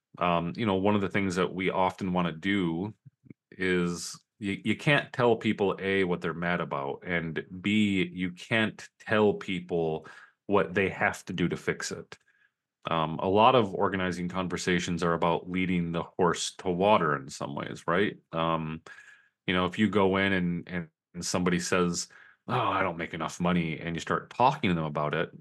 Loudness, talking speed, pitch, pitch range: -28 LUFS, 190 wpm, 90 Hz, 85-95 Hz